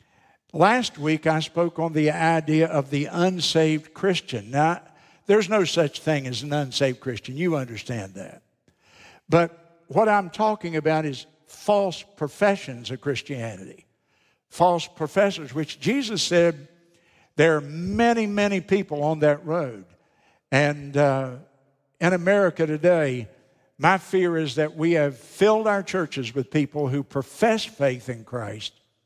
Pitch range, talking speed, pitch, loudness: 140-175 Hz, 140 wpm, 155 Hz, -23 LUFS